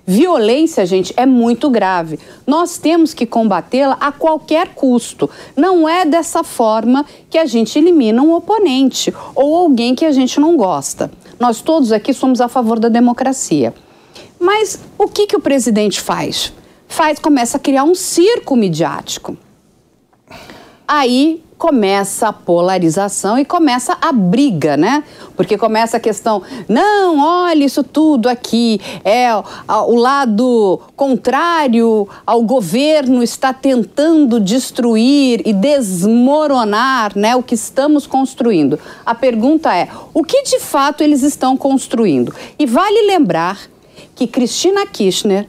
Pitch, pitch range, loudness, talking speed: 265 Hz, 230-310 Hz, -13 LUFS, 135 wpm